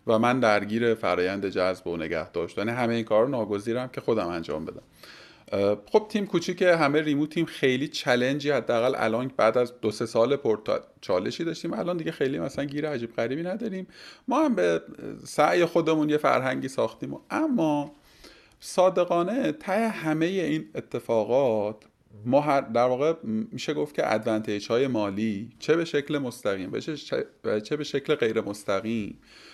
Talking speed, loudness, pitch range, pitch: 155 wpm, -26 LUFS, 110-165 Hz, 140 Hz